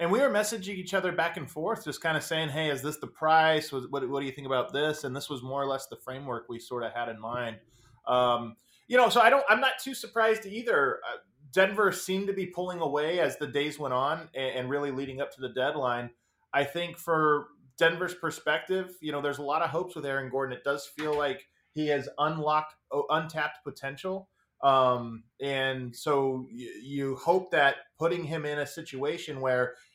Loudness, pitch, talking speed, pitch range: -29 LUFS, 145 Hz, 215 wpm, 135-165 Hz